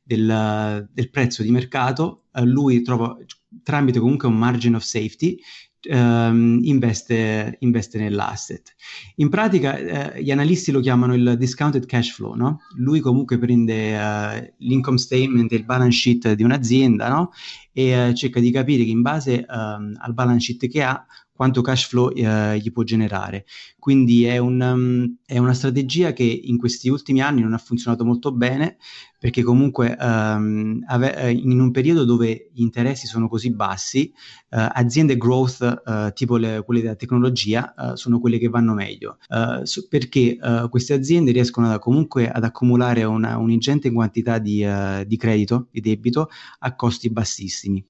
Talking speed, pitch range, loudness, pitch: 165 wpm, 115-130 Hz, -20 LUFS, 120 Hz